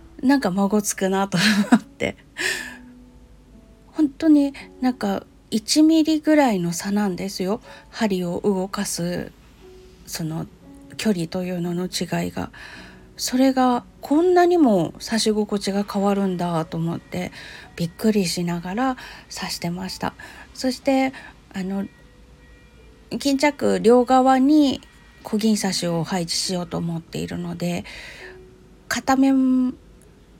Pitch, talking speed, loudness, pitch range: 205 Hz, 225 characters per minute, -21 LUFS, 175-260 Hz